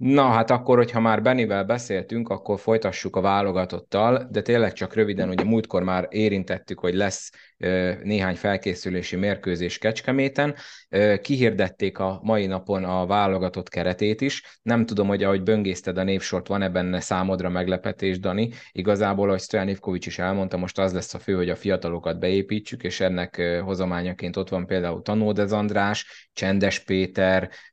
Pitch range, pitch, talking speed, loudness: 90-105 Hz, 95 Hz, 150 wpm, -24 LUFS